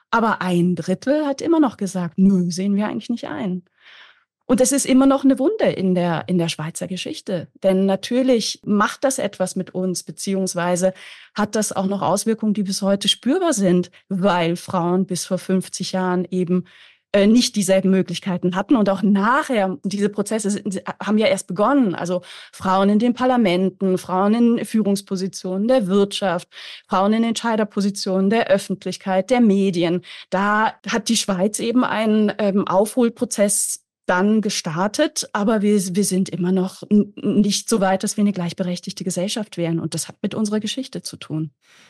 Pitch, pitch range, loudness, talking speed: 195 Hz, 185-220 Hz, -20 LUFS, 160 wpm